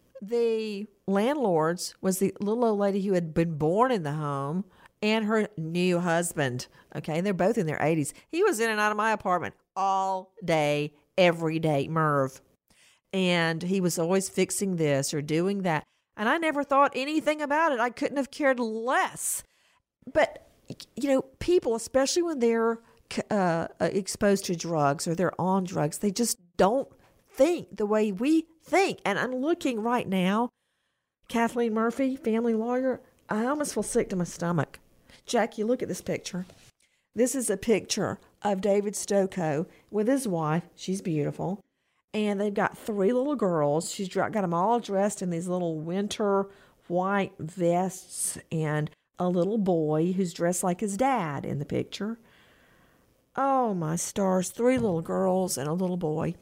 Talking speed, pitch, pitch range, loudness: 165 wpm, 195 Hz, 170-230 Hz, -27 LUFS